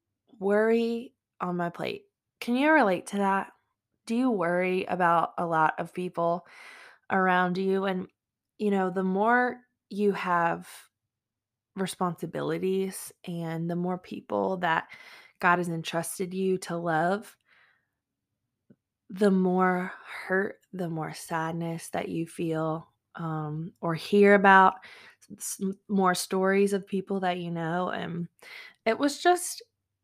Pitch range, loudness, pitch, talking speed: 170-205 Hz, -27 LUFS, 185 Hz, 125 wpm